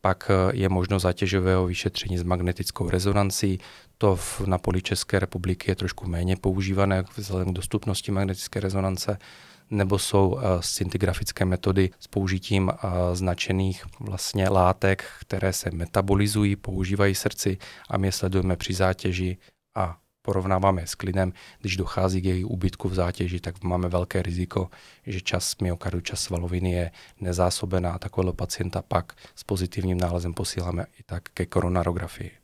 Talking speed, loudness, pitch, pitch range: 140 wpm, -26 LUFS, 95 Hz, 90-100 Hz